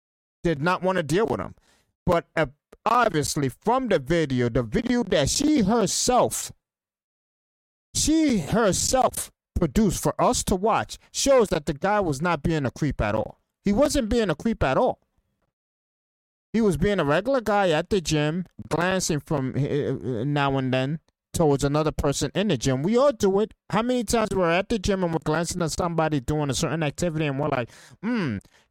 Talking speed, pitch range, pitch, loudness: 180 wpm, 145-210 Hz, 170 Hz, -24 LUFS